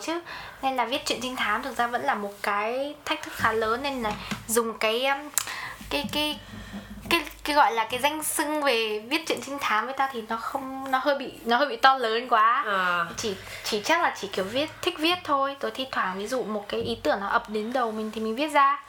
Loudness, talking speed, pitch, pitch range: -26 LUFS, 245 wpm, 260 Hz, 220-285 Hz